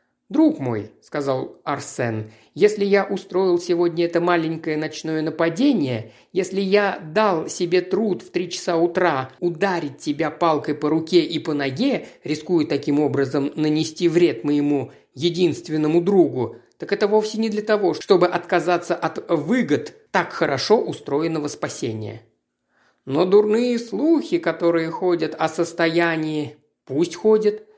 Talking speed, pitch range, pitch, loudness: 130 wpm, 150-195 Hz, 170 Hz, -21 LUFS